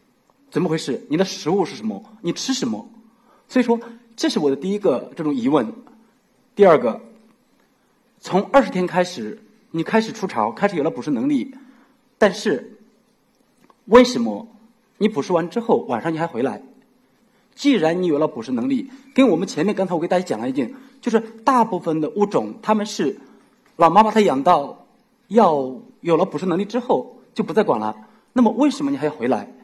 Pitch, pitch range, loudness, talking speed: 225 Hz, 190-250 Hz, -20 LUFS, 270 characters per minute